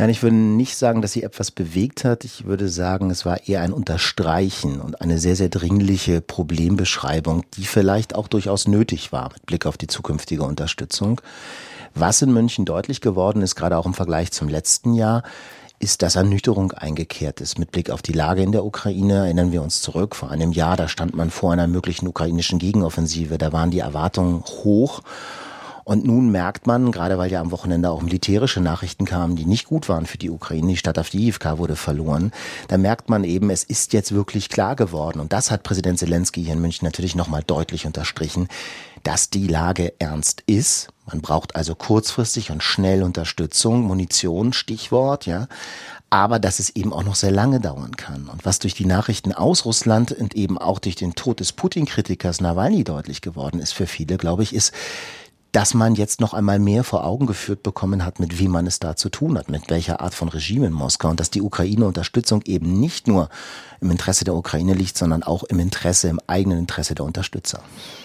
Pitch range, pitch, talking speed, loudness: 85-105 Hz, 95 Hz, 200 wpm, -20 LUFS